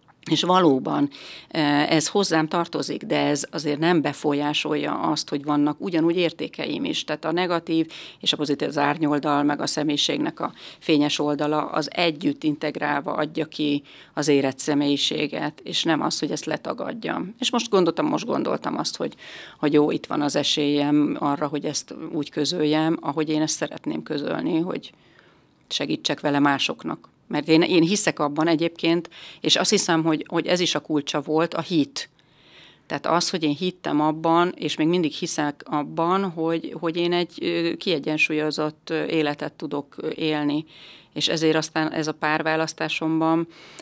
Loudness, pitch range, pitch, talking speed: -23 LUFS, 150-165 Hz, 155 Hz, 155 wpm